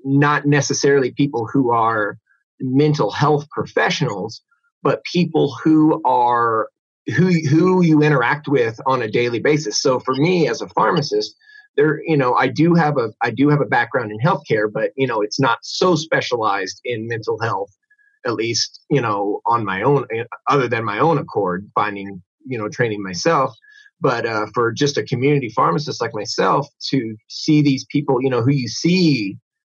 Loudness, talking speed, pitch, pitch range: -18 LUFS, 175 wpm, 140 Hz, 120-165 Hz